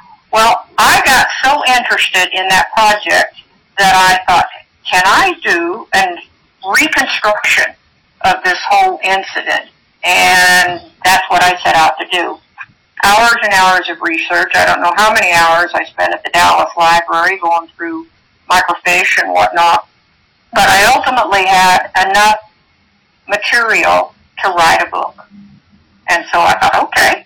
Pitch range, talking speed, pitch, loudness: 180-235 Hz, 145 wpm, 190 Hz, -10 LUFS